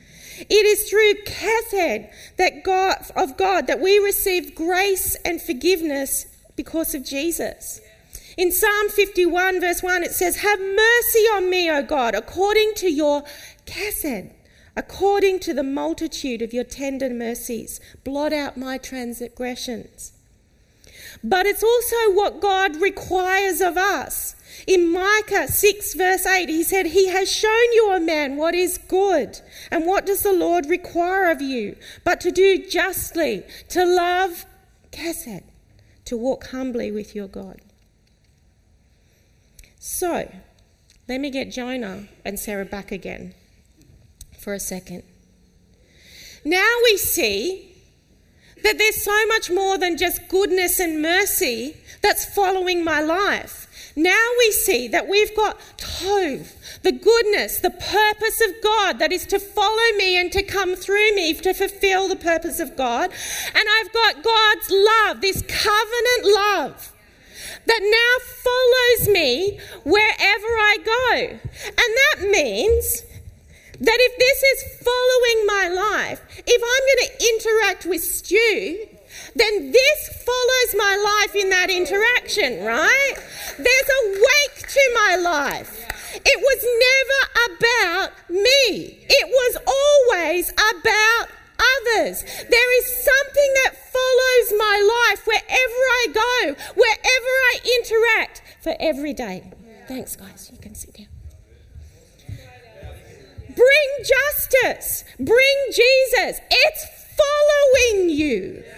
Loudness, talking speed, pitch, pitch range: -18 LUFS, 130 wpm, 380 Hz, 300-435 Hz